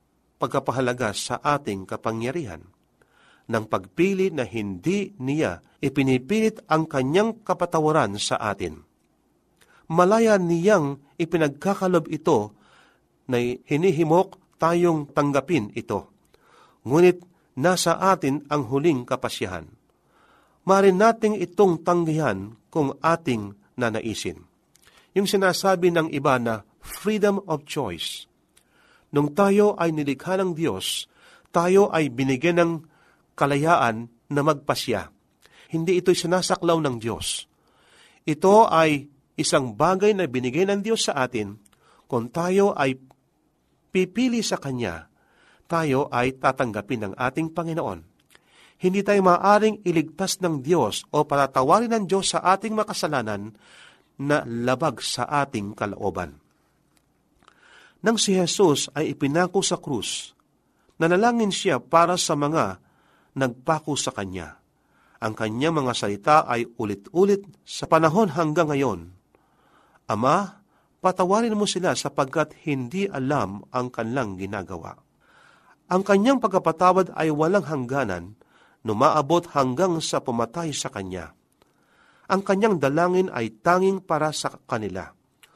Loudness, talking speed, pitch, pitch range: -23 LUFS, 110 wpm, 155 Hz, 125-180 Hz